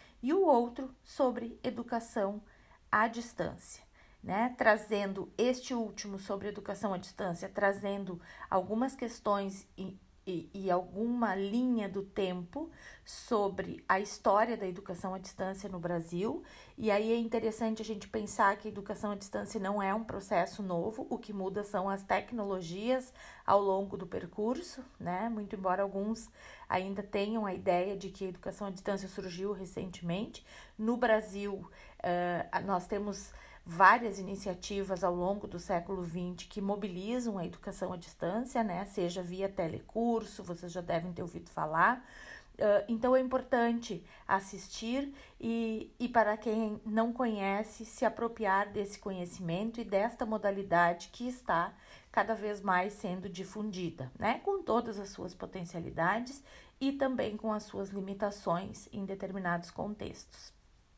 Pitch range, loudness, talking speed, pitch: 190-225 Hz, -34 LUFS, 145 wpm, 200 Hz